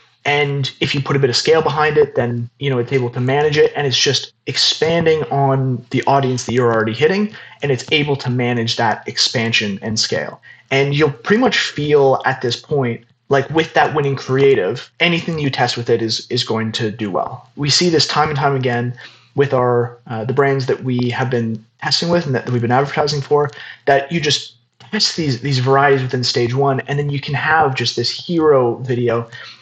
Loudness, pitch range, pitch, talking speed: -16 LUFS, 120-145 Hz, 135 Hz, 215 wpm